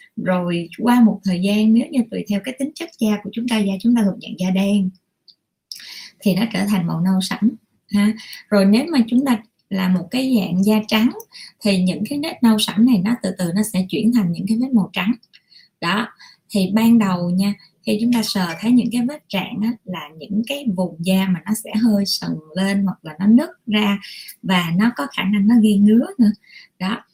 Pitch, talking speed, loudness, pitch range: 210 Hz, 225 wpm, -19 LUFS, 190-230 Hz